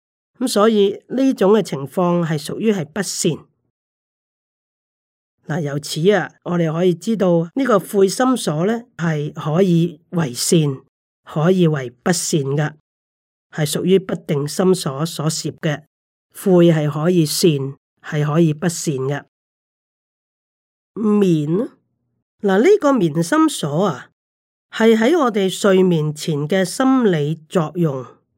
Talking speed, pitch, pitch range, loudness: 175 characters per minute, 175 Hz, 155-195 Hz, -18 LUFS